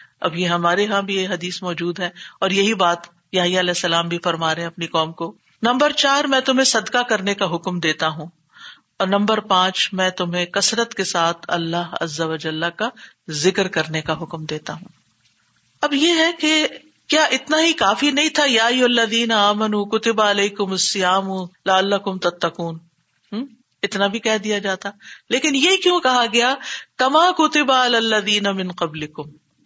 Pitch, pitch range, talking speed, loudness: 195 Hz, 170-235 Hz, 175 wpm, -18 LUFS